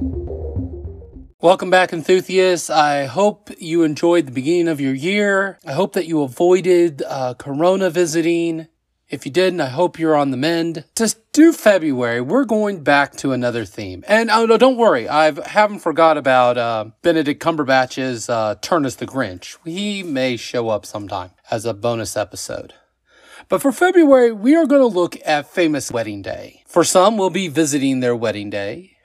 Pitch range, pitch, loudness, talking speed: 125-185 Hz, 160 Hz, -17 LUFS, 170 wpm